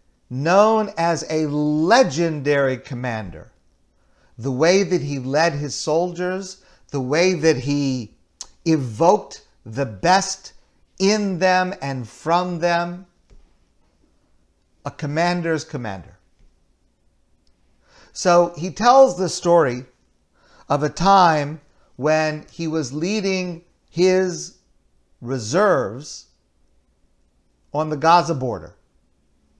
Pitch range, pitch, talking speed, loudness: 125-175 Hz, 155 Hz, 90 wpm, -20 LUFS